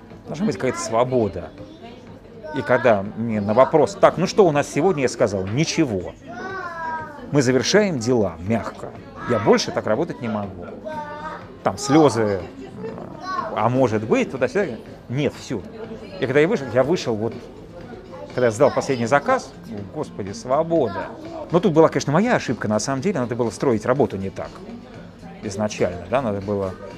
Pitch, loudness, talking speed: 130 Hz, -21 LUFS, 160 wpm